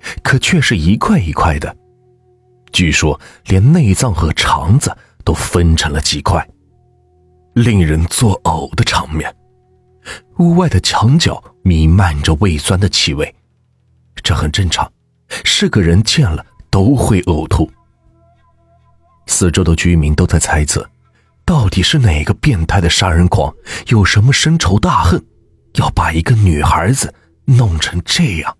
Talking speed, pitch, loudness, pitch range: 195 characters per minute, 90 Hz, -13 LUFS, 80-115 Hz